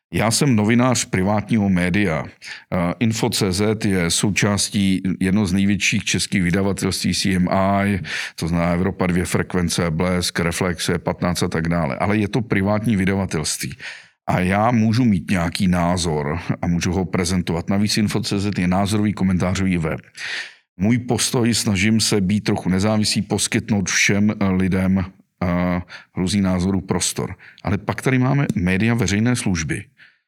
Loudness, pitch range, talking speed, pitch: -19 LUFS, 90-105 Hz, 135 wpm, 95 Hz